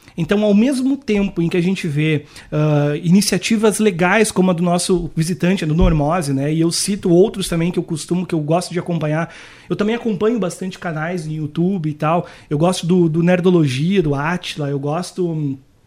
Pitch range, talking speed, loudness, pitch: 155-190 Hz, 195 wpm, -17 LUFS, 175 Hz